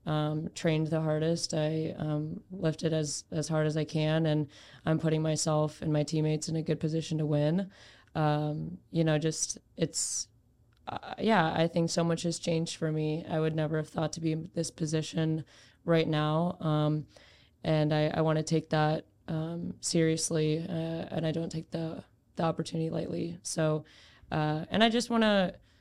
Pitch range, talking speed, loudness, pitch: 155-165 Hz, 185 wpm, -31 LUFS, 160 Hz